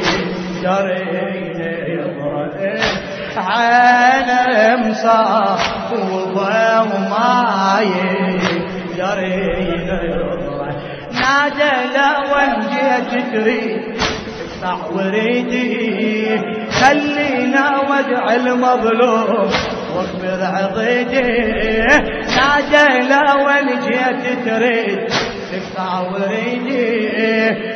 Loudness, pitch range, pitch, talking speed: -16 LUFS, 190-250 Hz, 225 Hz, 50 wpm